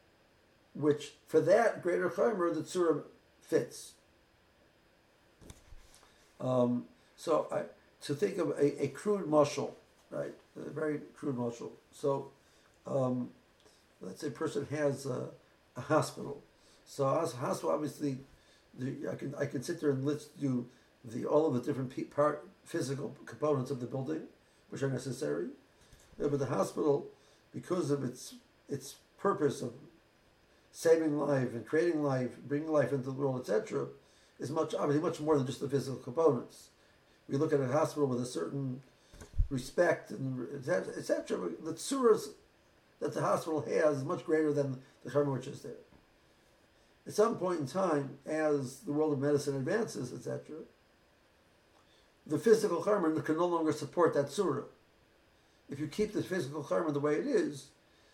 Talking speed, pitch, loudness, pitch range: 155 wpm, 145 Hz, -34 LUFS, 135-155 Hz